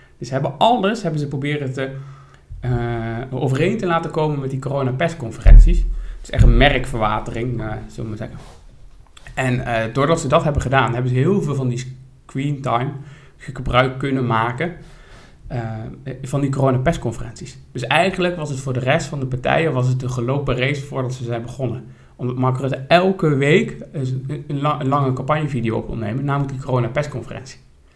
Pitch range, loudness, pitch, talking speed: 120-145 Hz, -20 LUFS, 130 Hz, 180 wpm